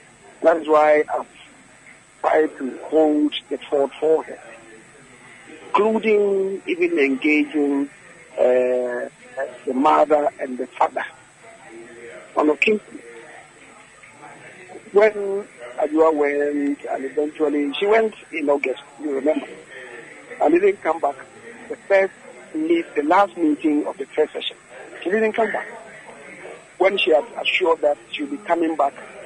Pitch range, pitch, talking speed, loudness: 145-215 Hz, 160 Hz, 125 wpm, -20 LUFS